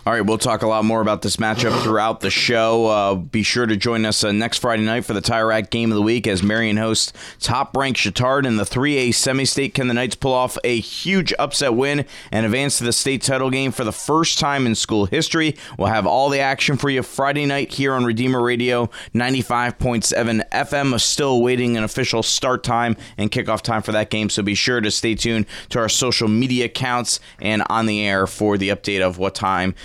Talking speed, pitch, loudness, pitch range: 225 wpm, 115 Hz, -19 LUFS, 110-130 Hz